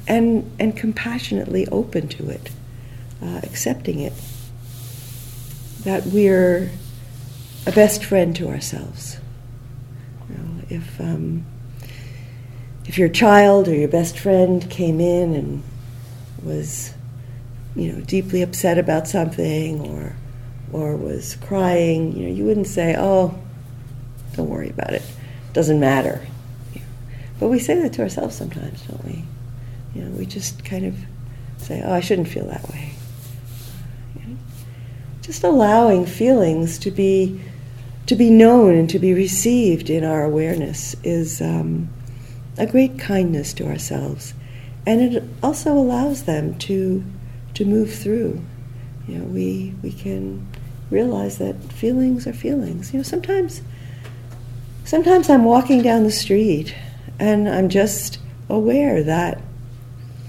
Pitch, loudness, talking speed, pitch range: 130 Hz, -19 LUFS, 135 wpm, 125-185 Hz